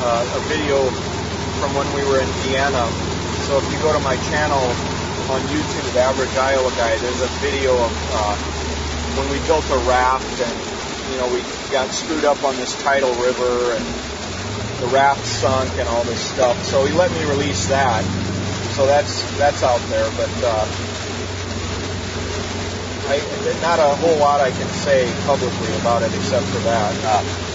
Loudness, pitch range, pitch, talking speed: -19 LUFS, 90-125 Hz, 105 Hz, 170 wpm